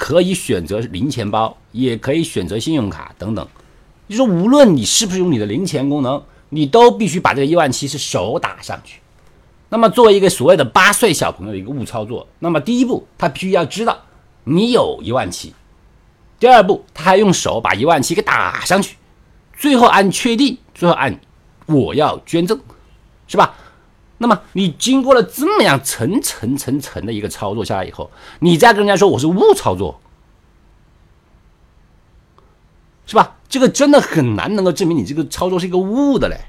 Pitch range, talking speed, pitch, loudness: 135-225 Hz, 275 characters per minute, 180 Hz, -15 LUFS